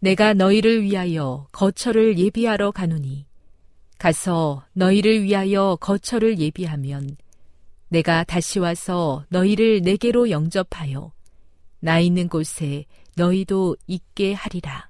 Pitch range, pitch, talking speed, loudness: 150-200 Hz, 175 Hz, 250 characters per minute, -20 LUFS